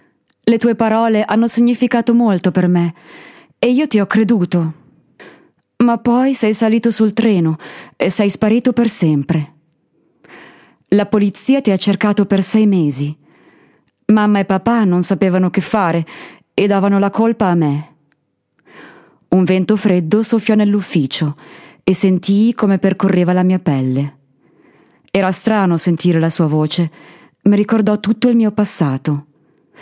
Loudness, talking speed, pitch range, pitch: -14 LUFS, 140 wpm, 170-220 Hz, 195 Hz